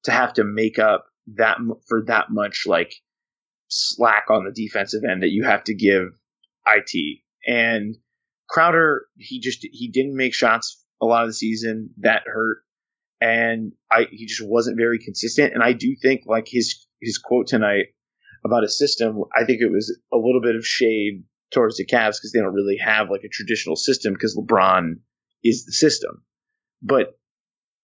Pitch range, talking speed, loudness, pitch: 110-120 Hz, 175 wpm, -20 LUFS, 115 Hz